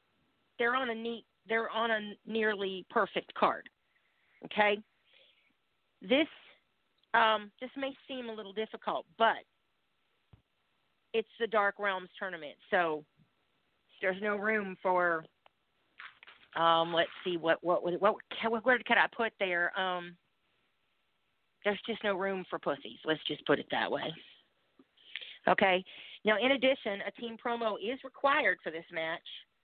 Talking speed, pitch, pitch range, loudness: 135 wpm, 210 Hz, 180-230 Hz, -32 LUFS